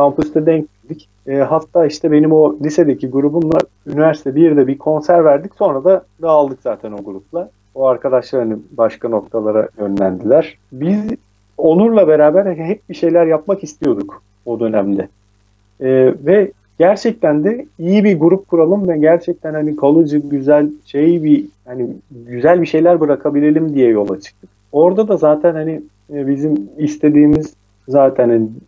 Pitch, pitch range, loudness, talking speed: 150 Hz, 125-165 Hz, -14 LUFS, 145 wpm